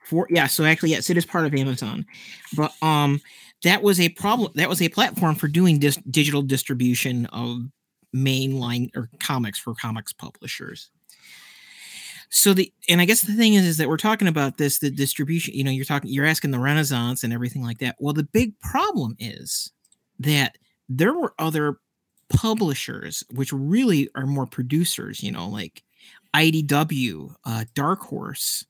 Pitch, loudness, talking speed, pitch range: 145 Hz, -22 LUFS, 170 wpm, 130-170 Hz